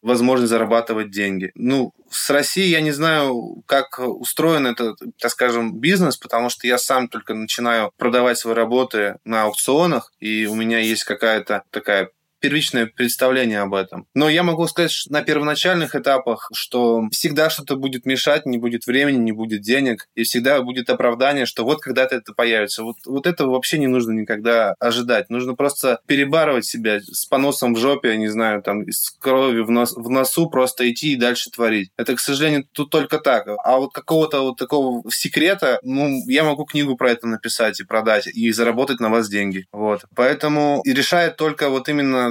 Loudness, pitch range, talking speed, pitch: -19 LUFS, 115-145 Hz, 180 wpm, 125 Hz